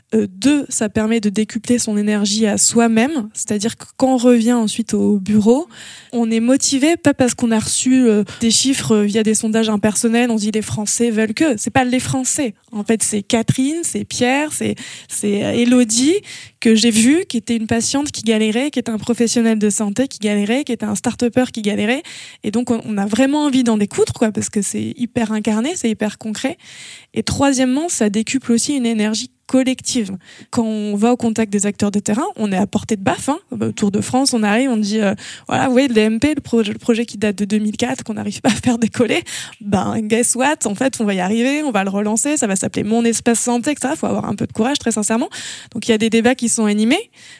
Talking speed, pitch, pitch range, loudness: 225 wpm, 230 Hz, 215-255 Hz, -17 LUFS